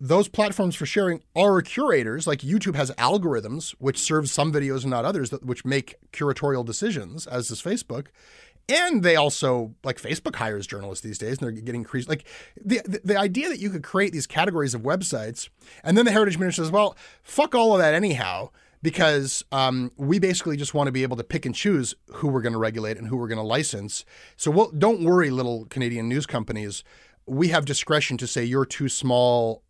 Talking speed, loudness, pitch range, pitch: 210 wpm, -24 LUFS, 125-185 Hz, 145 Hz